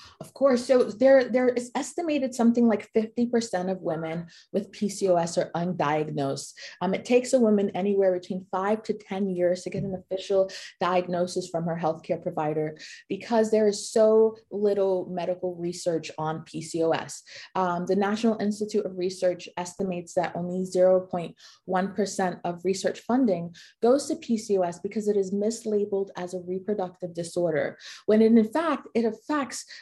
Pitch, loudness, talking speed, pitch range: 190 Hz, -26 LUFS, 150 wpm, 180-220 Hz